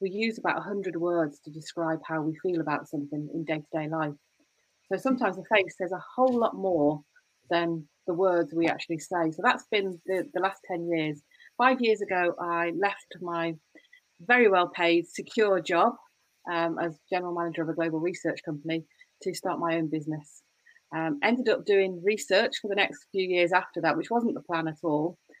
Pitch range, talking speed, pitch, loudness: 160-195 Hz, 195 wpm, 175 Hz, -28 LUFS